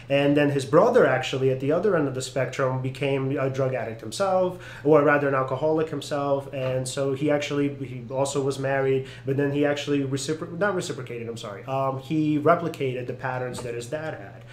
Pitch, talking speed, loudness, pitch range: 135 Hz, 200 wpm, -25 LUFS, 130-145 Hz